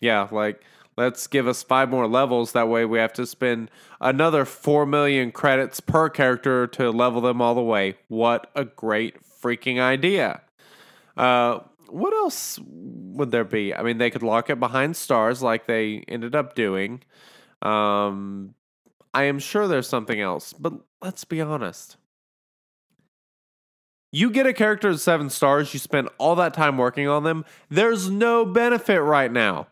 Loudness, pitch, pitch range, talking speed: -22 LUFS, 130 Hz, 115-150 Hz, 165 wpm